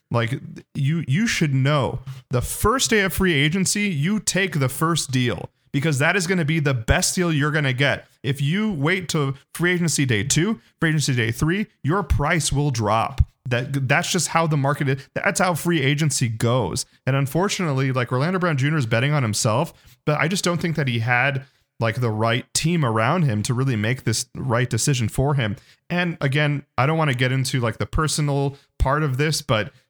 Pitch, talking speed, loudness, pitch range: 140 Hz, 205 wpm, -21 LUFS, 125-165 Hz